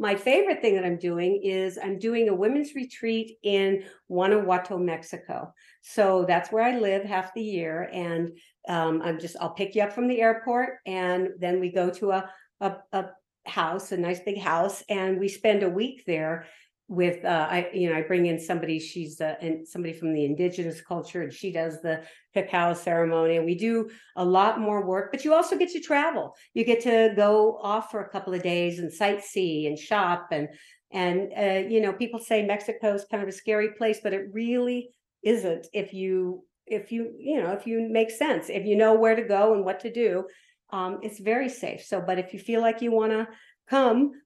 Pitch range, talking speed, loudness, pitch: 180-225 Hz, 210 wpm, -26 LUFS, 195 Hz